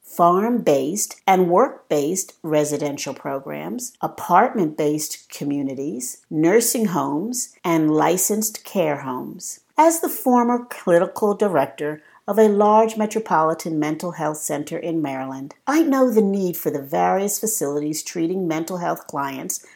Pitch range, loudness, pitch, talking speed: 150-215 Hz, -21 LUFS, 170 Hz, 120 wpm